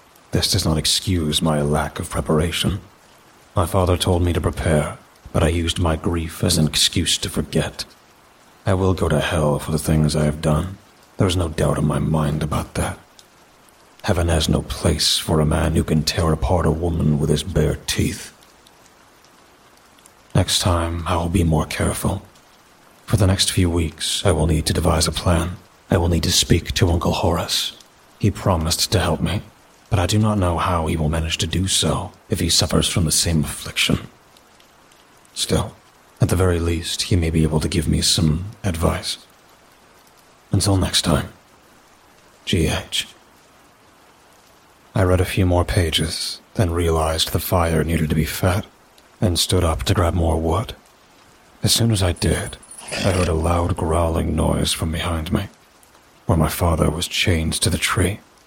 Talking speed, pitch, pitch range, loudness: 180 wpm, 85 Hz, 80-95 Hz, -20 LUFS